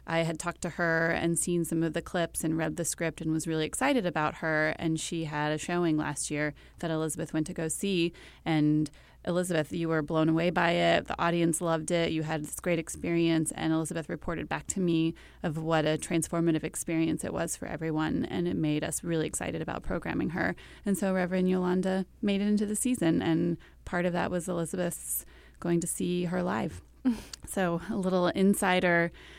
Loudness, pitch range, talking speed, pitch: -30 LUFS, 160-180 Hz, 200 wpm, 170 Hz